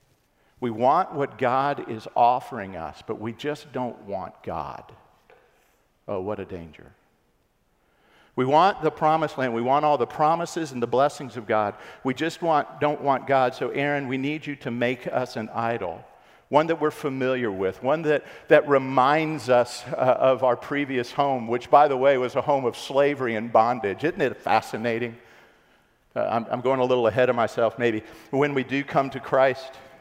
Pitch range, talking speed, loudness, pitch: 120-145 Hz, 190 wpm, -24 LUFS, 130 Hz